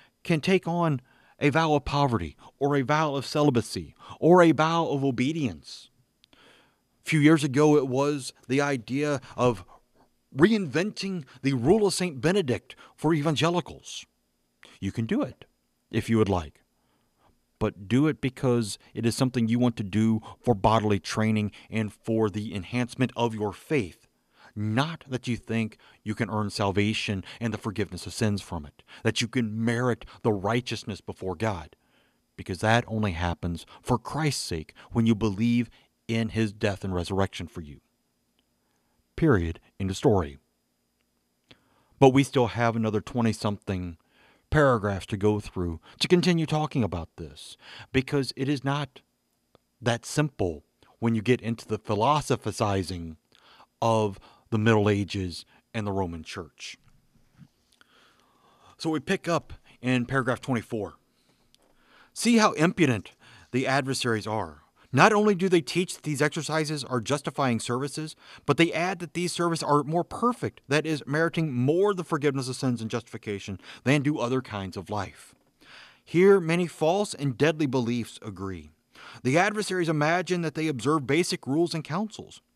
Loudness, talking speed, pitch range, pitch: -26 LUFS, 150 wpm, 105-150 Hz, 120 Hz